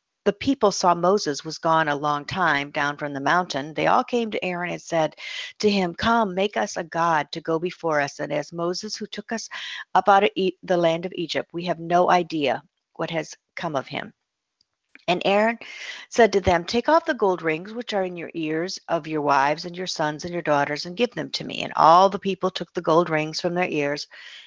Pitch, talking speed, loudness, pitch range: 175 Hz, 230 wpm, -23 LUFS, 155-195 Hz